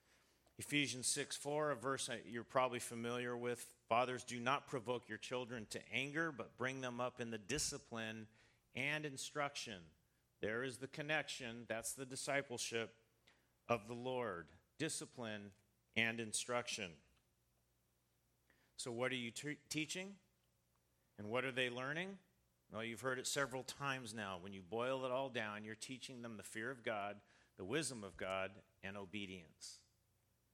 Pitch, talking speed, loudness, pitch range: 120 Hz, 150 wpm, -44 LUFS, 105-130 Hz